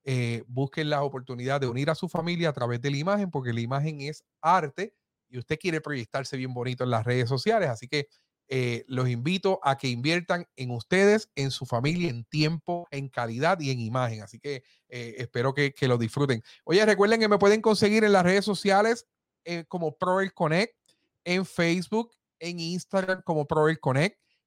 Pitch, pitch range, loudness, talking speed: 150 Hz, 130-180 Hz, -27 LUFS, 190 wpm